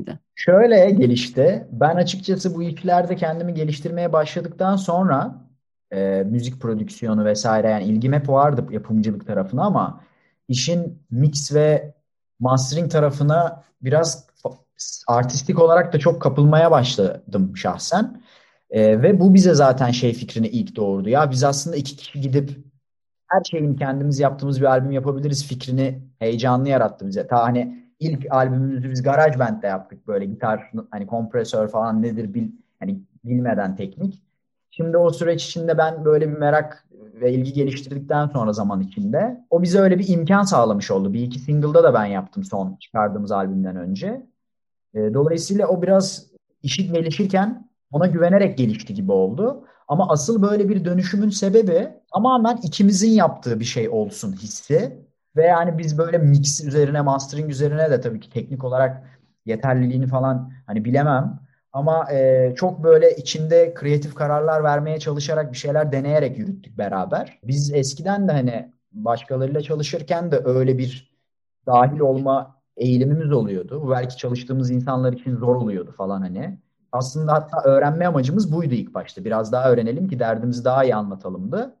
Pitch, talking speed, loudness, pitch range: 140 Hz, 145 wpm, -20 LUFS, 125-170 Hz